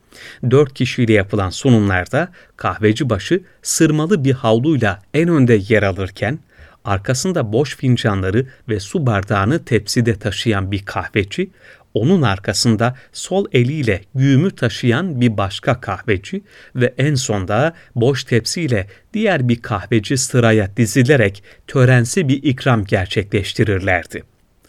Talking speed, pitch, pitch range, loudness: 115 wpm, 120 Hz, 105-140 Hz, -17 LUFS